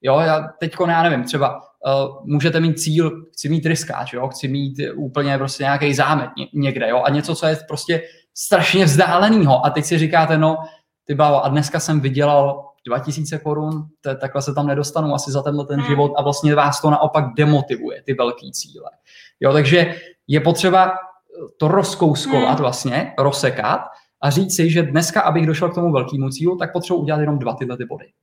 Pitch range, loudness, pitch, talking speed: 140-165 Hz, -18 LUFS, 150 Hz, 185 wpm